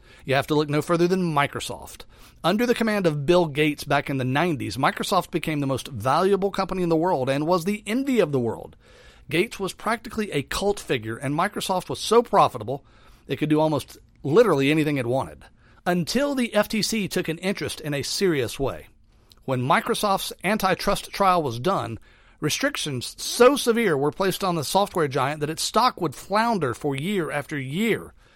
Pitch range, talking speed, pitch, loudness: 140-200 Hz, 185 wpm, 165 Hz, -23 LUFS